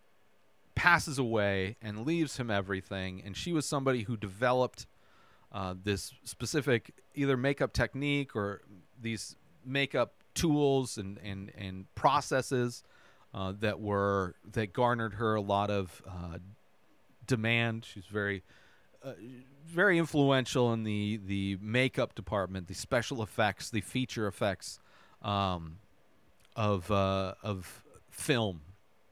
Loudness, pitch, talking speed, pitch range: -32 LUFS, 110 Hz, 120 wpm, 100-130 Hz